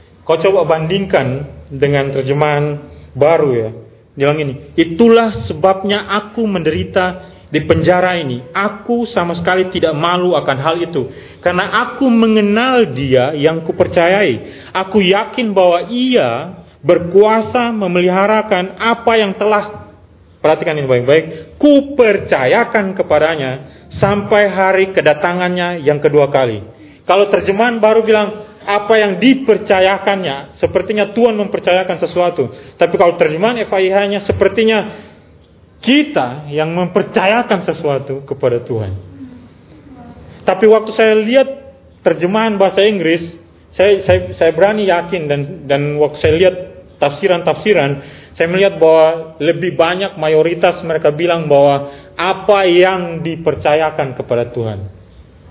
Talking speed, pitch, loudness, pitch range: 110 wpm, 180 Hz, -13 LUFS, 150-205 Hz